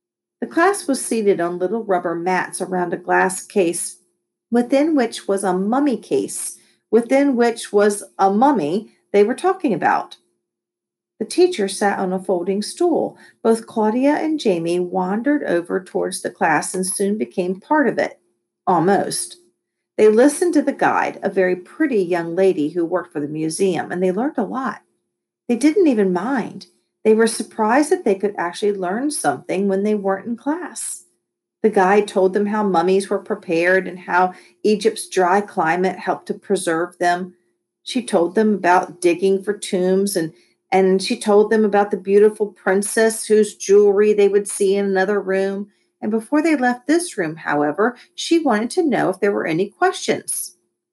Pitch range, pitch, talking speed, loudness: 185-235 Hz, 205 Hz, 170 wpm, -19 LUFS